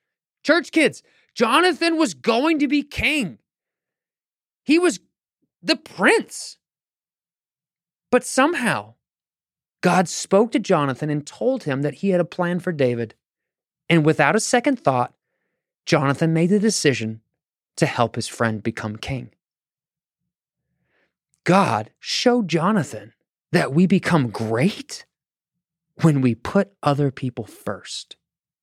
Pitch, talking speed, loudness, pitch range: 170 Hz, 115 wpm, -20 LUFS, 140-235 Hz